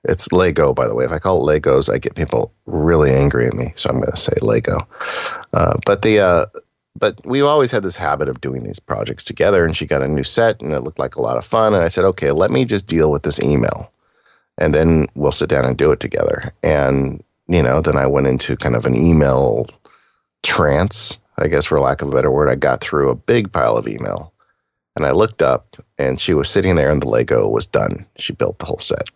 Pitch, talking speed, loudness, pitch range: 80 Hz, 245 wpm, -16 LUFS, 70-115 Hz